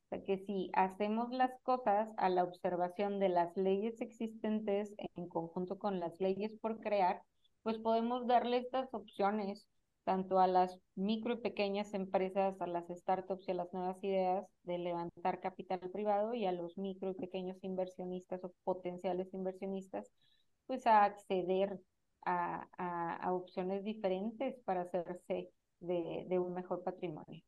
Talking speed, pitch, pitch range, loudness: 155 wpm, 190 Hz, 180-205 Hz, -38 LUFS